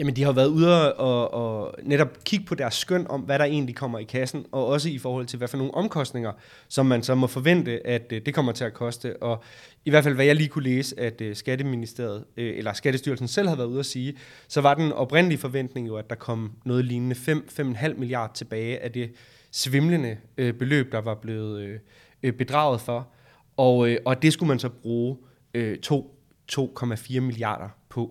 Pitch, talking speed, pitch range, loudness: 130 Hz, 195 wpm, 120-140 Hz, -25 LUFS